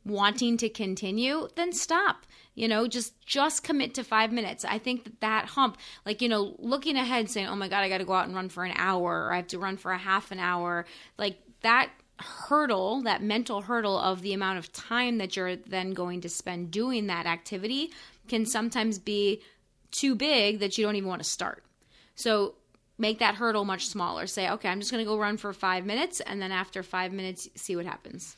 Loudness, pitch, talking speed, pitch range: -29 LUFS, 205 Hz, 220 wpm, 190-235 Hz